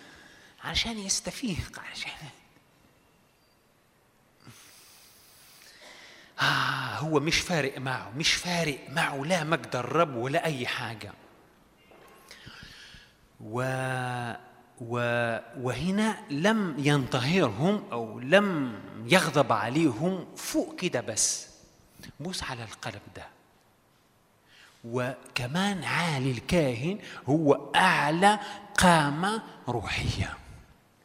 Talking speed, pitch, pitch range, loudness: 75 wpm, 145 Hz, 125-175 Hz, -28 LUFS